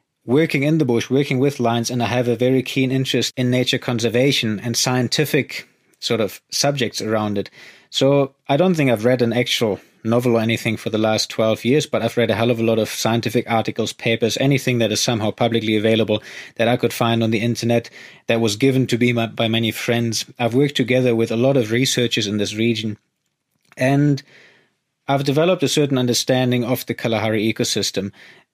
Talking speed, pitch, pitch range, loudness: 200 wpm, 120 Hz, 115-130 Hz, -19 LUFS